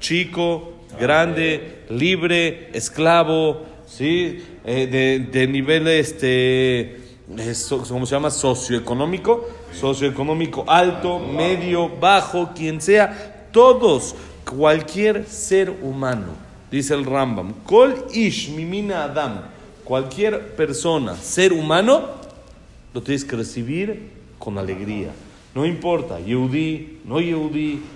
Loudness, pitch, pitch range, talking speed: -19 LUFS, 155 Hz, 130-175 Hz, 100 wpm